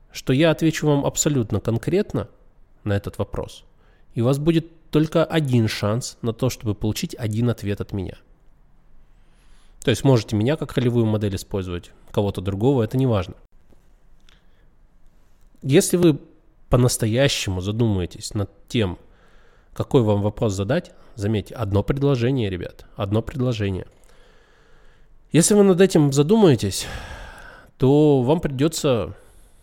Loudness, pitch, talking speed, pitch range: -21 LUFS, 120 Hz, 125 wpm, 105-145 Hz